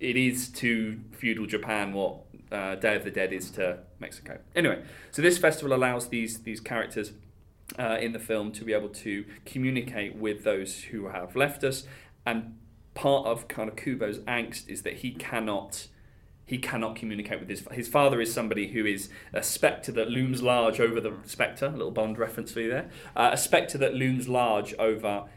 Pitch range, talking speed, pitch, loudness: 105-125 Hz, 190 wpm, 115 Hz, -29 LUFS